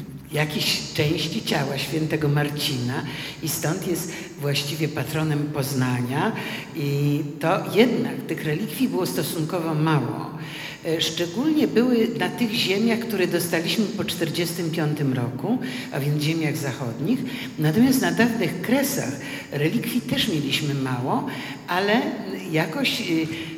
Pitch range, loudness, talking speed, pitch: 145-190 Hz, -24 LUFS, 110 wpm, 160 Hz